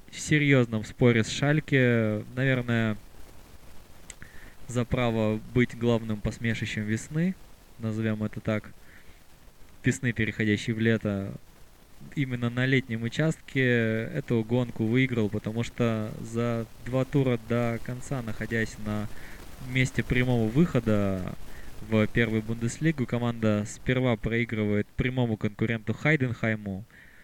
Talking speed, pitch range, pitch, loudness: 105 wpm, 110-125 Hz, 115 Hz, -27 LUFS